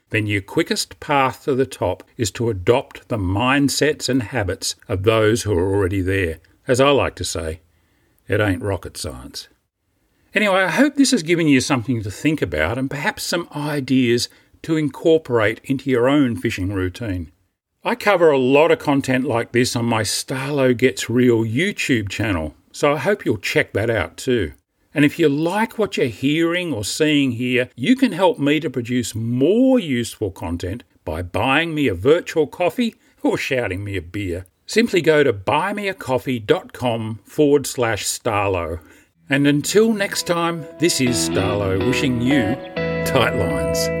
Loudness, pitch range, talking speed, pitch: -19 LUFS, 105-160 Hz, 165 wpm, 130 Hz